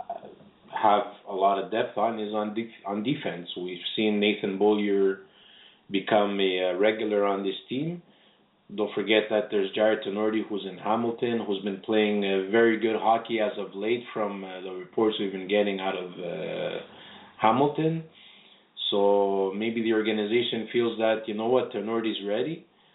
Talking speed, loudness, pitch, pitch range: 165 wpm, -27 LUFS, 105 Hz, 100-115 Hz